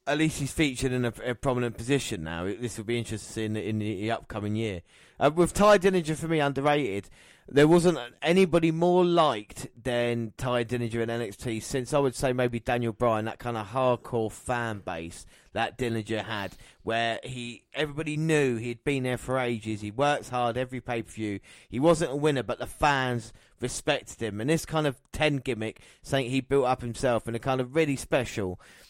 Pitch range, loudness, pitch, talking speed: 110-140 Hz, -28 LUFS, 125 Hz, 195 wpm